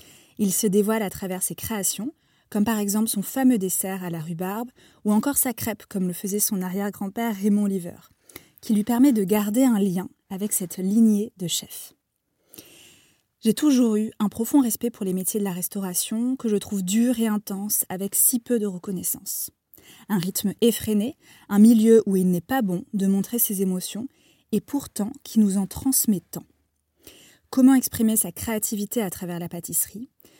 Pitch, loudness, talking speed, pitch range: 210 Hz, -23 LUFS, 180 wpm, 195-235 Hz